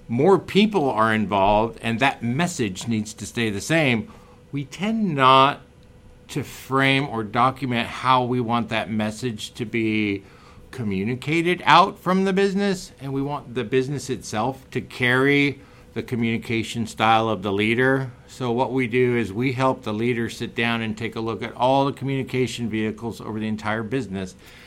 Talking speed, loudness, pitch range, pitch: 170 wpm, -22 LUFS, 110-135 Hz, 120 Hz